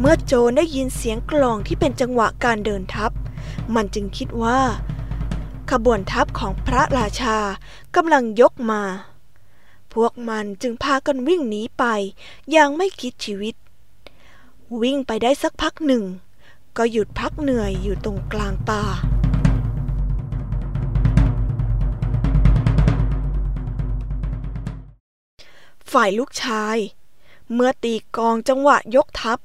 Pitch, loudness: 215 Hz, -21 LUFS